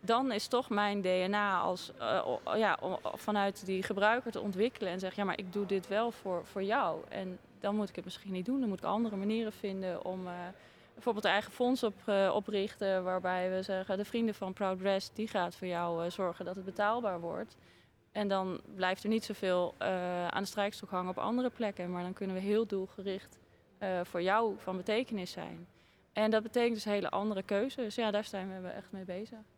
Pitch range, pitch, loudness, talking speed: 185-215 Hz, 200 Hz, -35 LUFS, 215 wpm